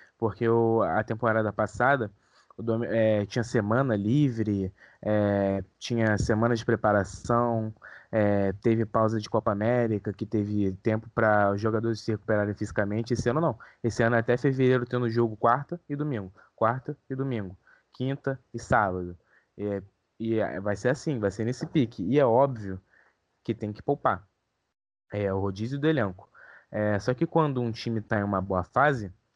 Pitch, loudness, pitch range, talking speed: 110 Hz, -27 LUFS, 105-120 Hz, 165 wpm